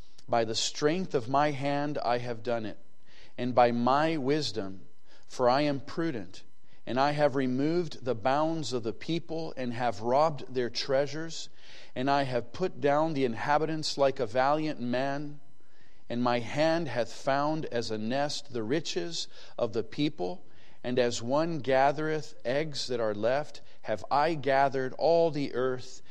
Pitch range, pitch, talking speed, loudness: 120-150 Hz, 135 Hz, 160 wpm, -30 LUFS